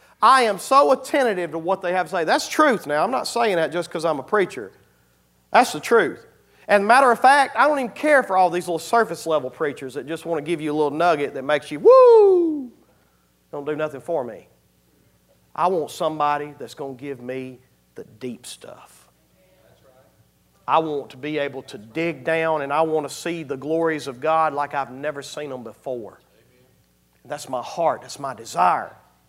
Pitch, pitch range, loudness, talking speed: 155 Hz, 130-180 Hz, -20 LUFS, 200 wpm